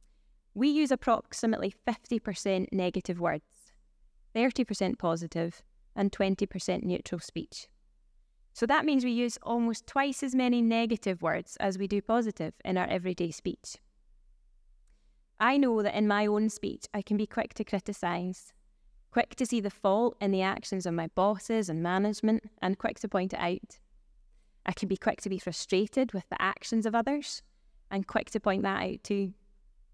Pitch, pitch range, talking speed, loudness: 205 Hz, 185-230 Hz, 165 wpm, -31 LUFS